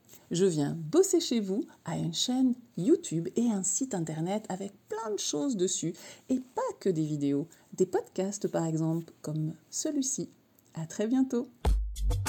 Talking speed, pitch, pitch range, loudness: 155 wpm, 190 Hz, 160-255 Hz, -31 LUFS